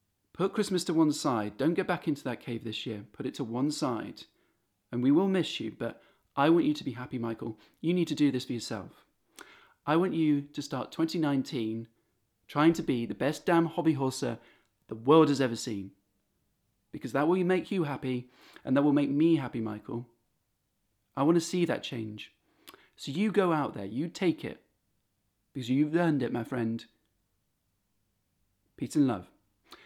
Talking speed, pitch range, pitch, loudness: 185 wpm, 110-160 Hz, 130 Hz, -30 LUFS